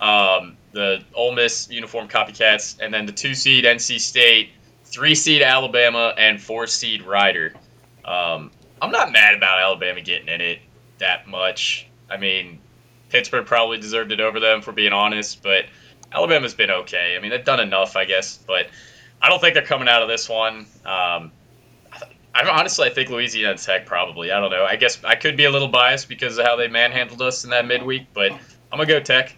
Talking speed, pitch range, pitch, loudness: 200 wpm, 105-125 Hz, 115 Hz, -17 LUFS